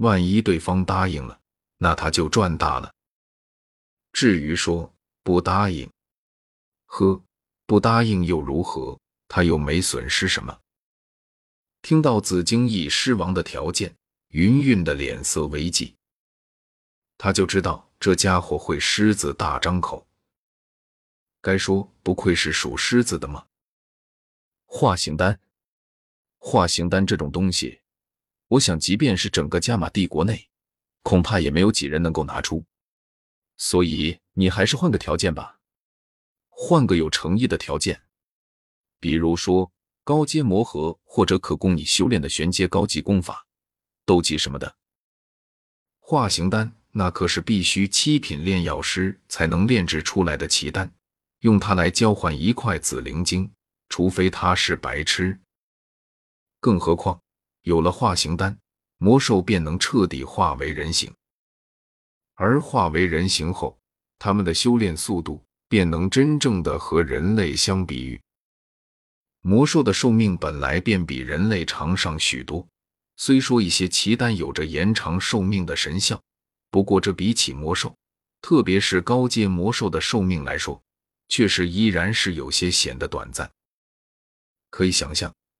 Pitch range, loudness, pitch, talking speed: 80-105 Hz, -21 LUFS, 90 Hz, 205 characters per minute